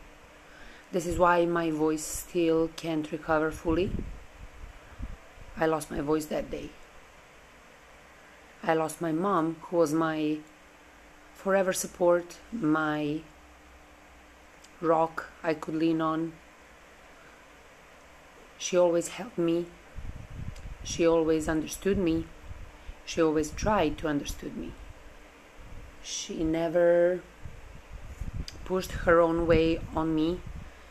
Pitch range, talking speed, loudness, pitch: 110-170 Hz, 100 wpm, -28 LUFS, 160 Hz